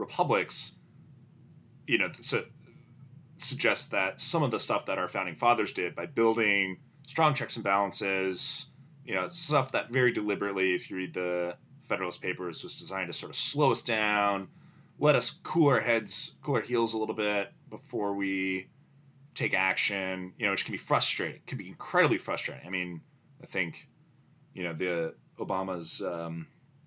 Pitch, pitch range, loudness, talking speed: 110 Hz, 95-140 Hz, -29 LUFS, 165 wpm